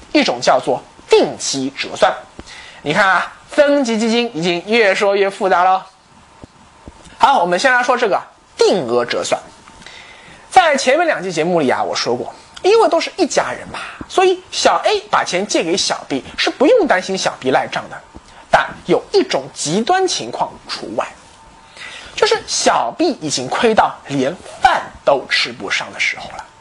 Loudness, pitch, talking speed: -16 LUFS, 255 Hz, 230 characters per minute